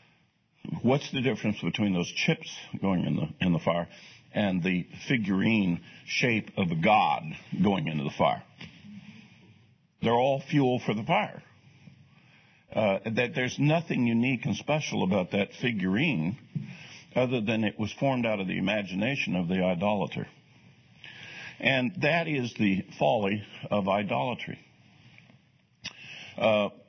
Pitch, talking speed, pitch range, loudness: 110 Hz, 140 wpm, 95-130 Hz, -28 LUFS